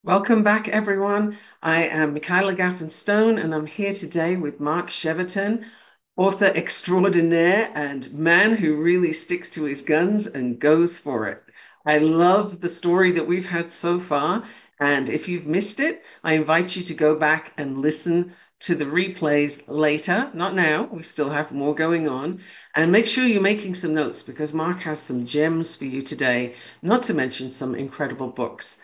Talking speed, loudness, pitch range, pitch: 175 wpm, -22 LUFS, 150-185 Hz, 165 Hz